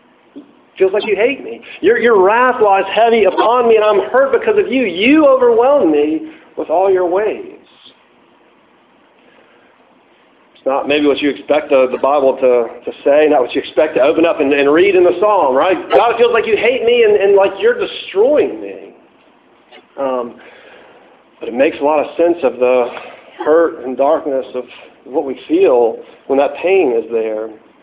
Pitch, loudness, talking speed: 200 Hz, -13 LUFS, 185 wpm